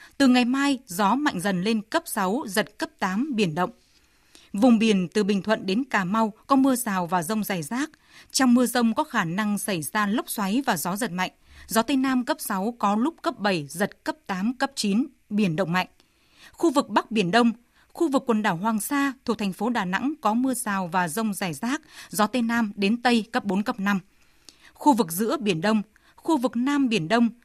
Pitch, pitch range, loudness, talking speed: 225 Hz, 205-260 Hz, -24 LUFS, 225 wpm